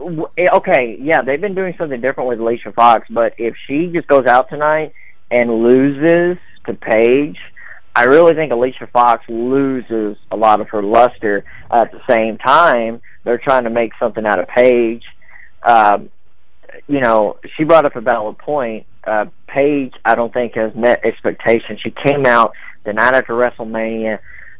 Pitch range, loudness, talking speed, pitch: 115-135 Hz, -14 LUFS, 170 wpm, 120 Hz